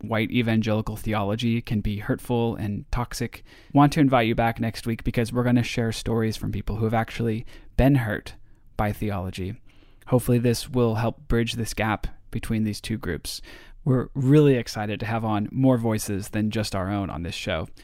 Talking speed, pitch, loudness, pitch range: 190 wpm, 115 Hz, -25 LUFS, 105-120 Hz